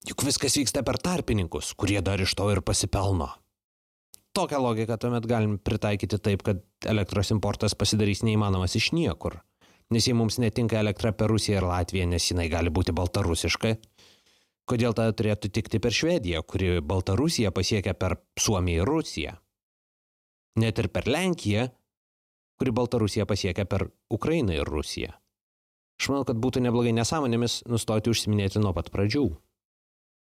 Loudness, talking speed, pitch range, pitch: -26 LUFS, 145 wpm, 95-115 Hz, 105 Hz